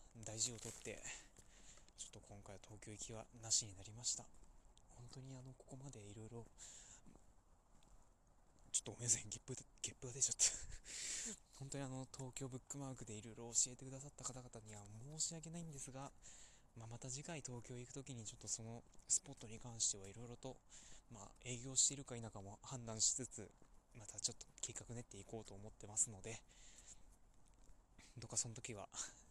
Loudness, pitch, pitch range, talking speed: -44 LUFS, 120 Hz, 110-130 Hz, 360 characters per minute